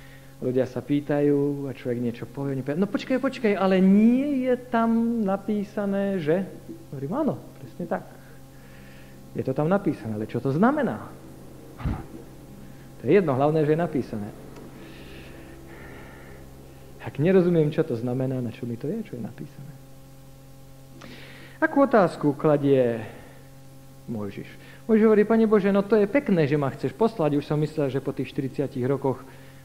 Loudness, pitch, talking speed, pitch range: -24 LUFS, 135 Hz, 150 wpm, 120-190 Hz